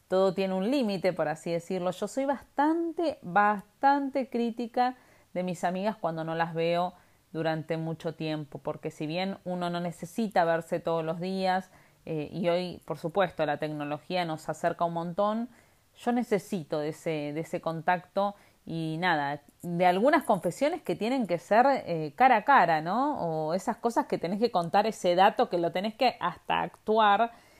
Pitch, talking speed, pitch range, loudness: 180 Hz, 170 wpm, 165-220 Hz, -29 LUFS